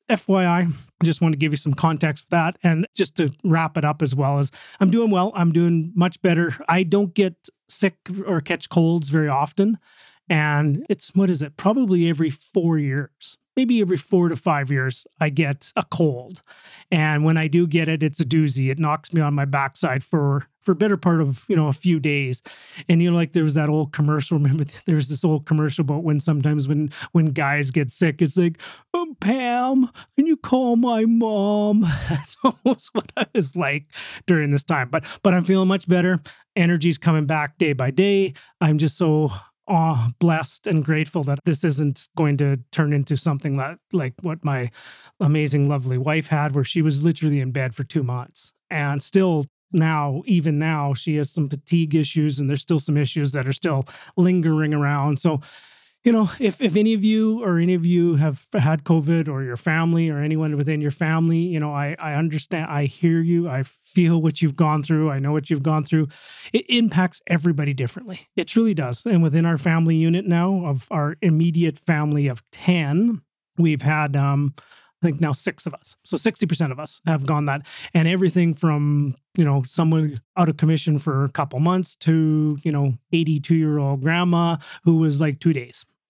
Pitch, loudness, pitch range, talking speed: 160 Hz, -21 LUFS, 145-175 Hz, 200 wpm